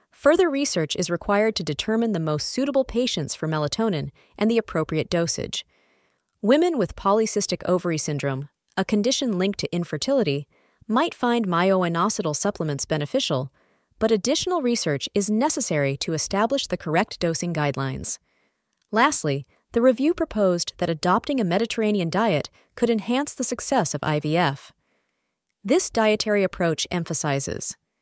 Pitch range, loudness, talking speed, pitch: 160-235 Hz, -23 LUFS, 130 wpm, 195 Hz